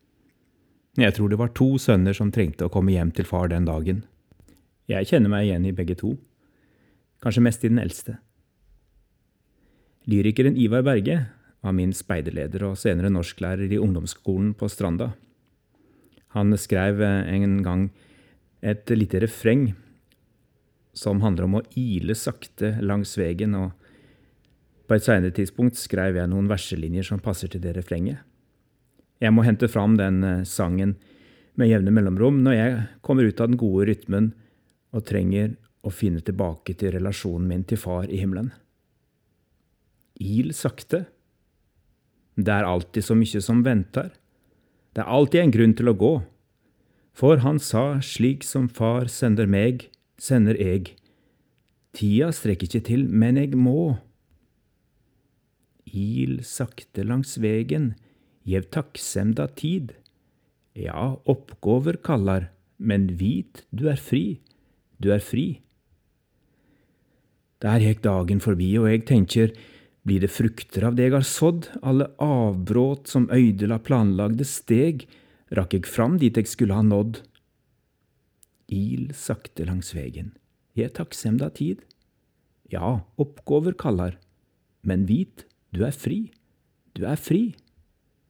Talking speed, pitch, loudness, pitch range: 135 wpm, 105 Hz, -23 LUFS, 95-125 Hz